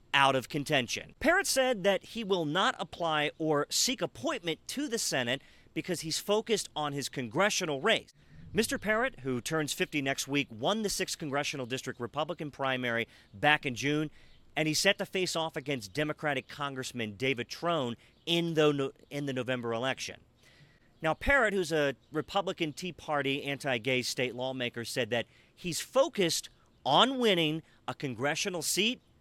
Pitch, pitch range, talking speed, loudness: 150 Hz, 130-180 Hz, 155 wpm, -31 LUFS